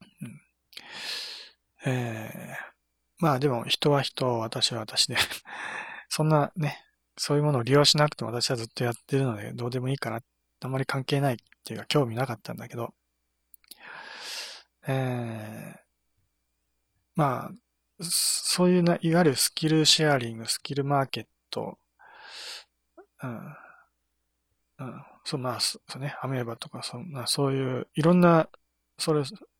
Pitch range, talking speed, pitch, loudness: 110-150 Hz, 270 characters per minute, 130 Hz, -27 LUFS